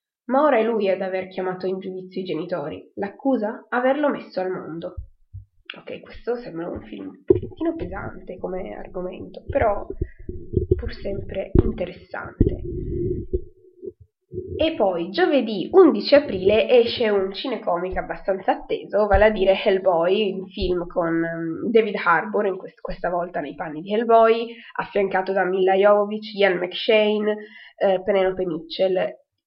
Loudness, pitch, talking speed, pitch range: -22 LUFS, 200 Hz, 135 wpm, 185-235 Hz